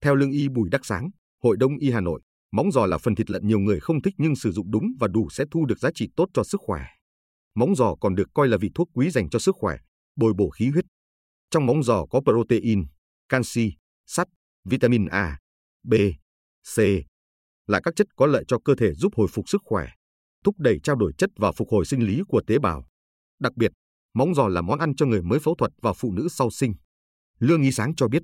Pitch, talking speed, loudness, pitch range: 115 Hz, 240 wpm, -23 LUFS, 85-140 Hz